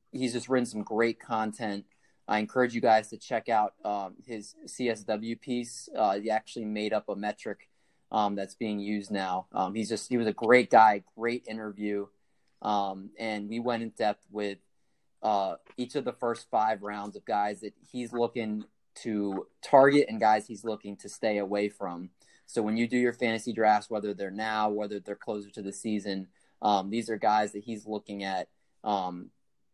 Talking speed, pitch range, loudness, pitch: 190 wpm, 100-115 Hz, -30 LUFS, 105 Hz